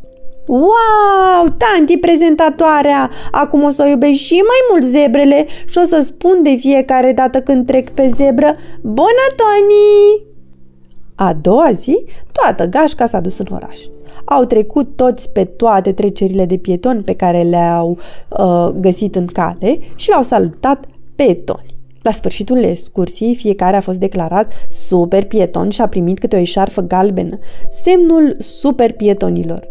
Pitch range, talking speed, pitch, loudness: 185-300 Hz, 145 wpm, 250 Hz, -12 LUFS